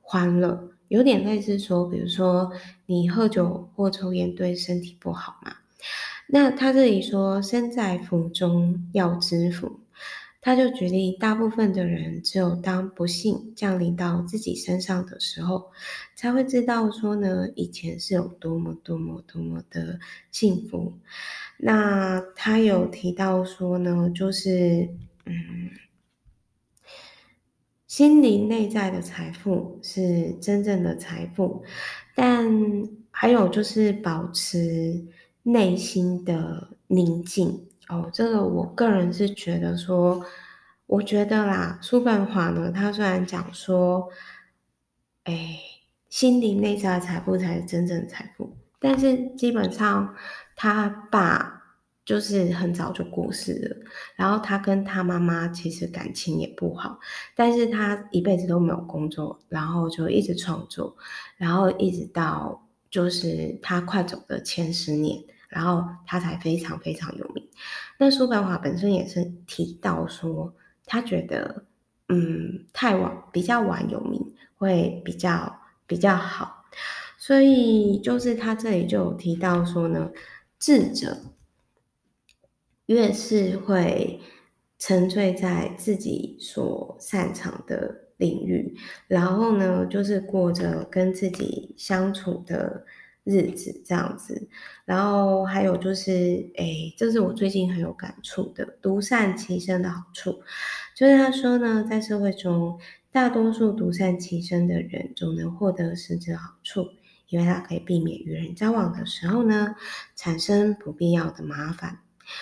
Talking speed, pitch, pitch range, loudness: 195 characters per minute, 185 Hz, 175-210 Hz, -24 LUFS